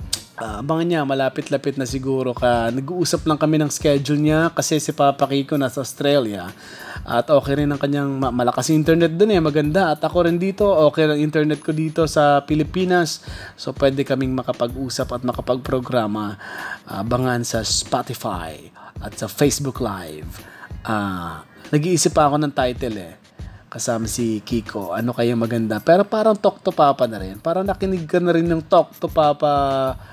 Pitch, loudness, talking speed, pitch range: 140 Hz, -20 LUFS, 165 wpm, 120-155 Hz